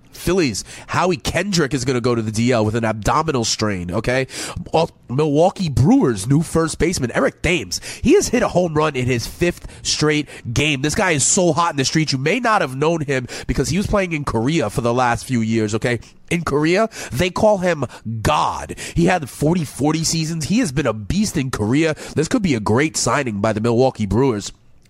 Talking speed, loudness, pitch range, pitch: 210 wpm, -19 LUFS, 120-165 Hz, 140 Hz